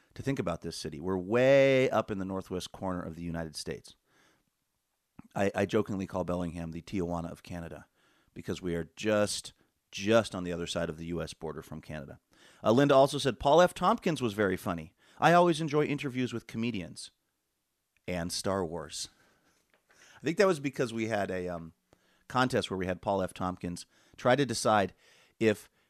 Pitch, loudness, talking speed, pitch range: 95 Hz, -30 LUFS, 185 wpm, 85-125 Hz